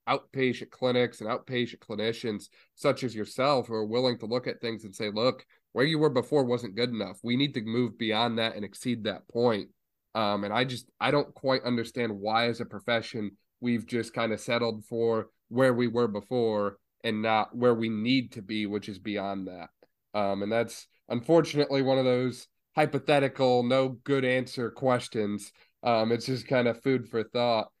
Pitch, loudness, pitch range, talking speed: 120 Hz, -29 LUFS, 110-125 Hz, 190 wpm